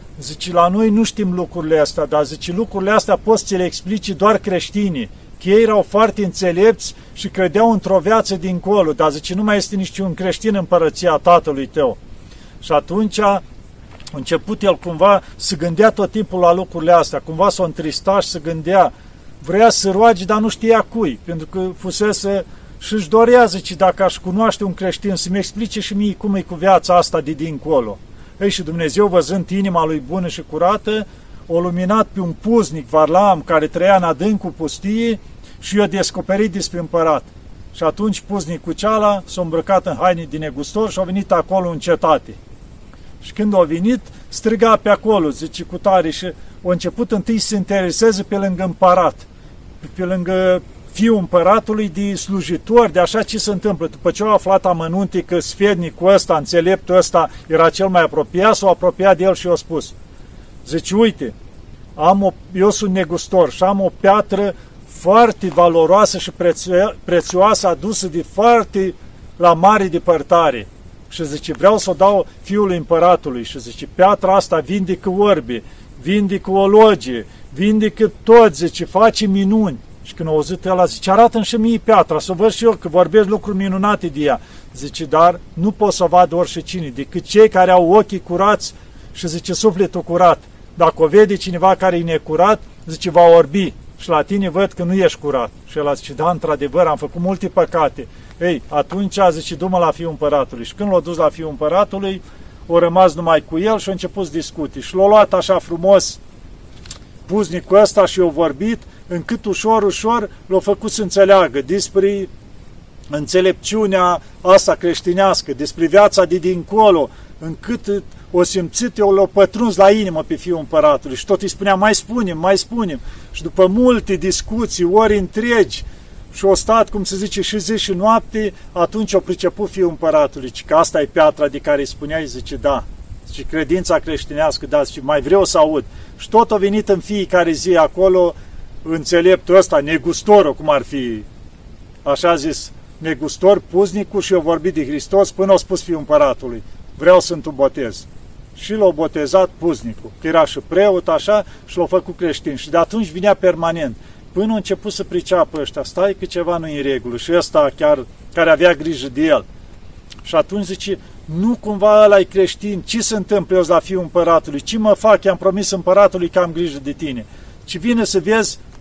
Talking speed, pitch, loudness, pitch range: 180 wpm, 185 Hz, -15 LUFS, 165-205 Hz